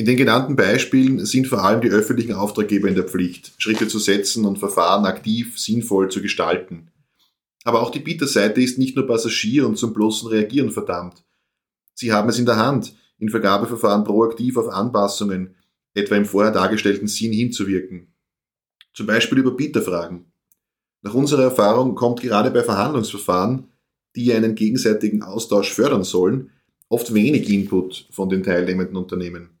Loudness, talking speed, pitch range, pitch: -19 LUFS, 155 wpm, 100-120 Hz, 105 Hz